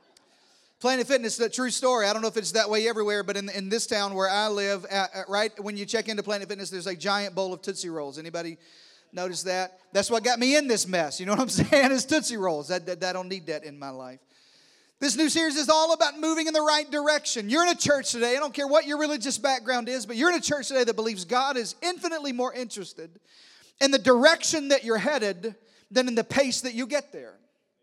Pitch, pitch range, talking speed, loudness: 230 Hz, 195-275 Hz, 250 wpm, -25 LUFS